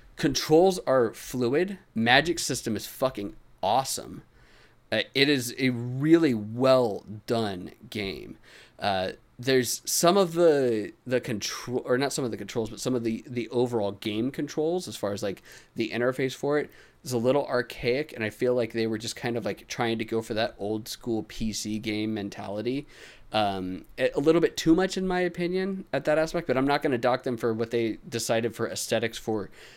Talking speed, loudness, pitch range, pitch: 190 wpm, -27 LUFS, 110-140 Hz, 120 Hz